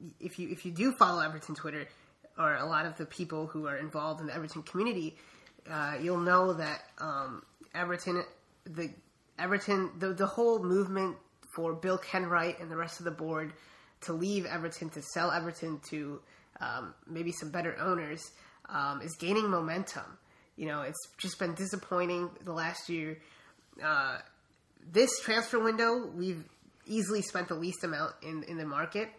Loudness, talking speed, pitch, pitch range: -33 LUFS, 165 wpm, 170 Hz, 160-185 Hz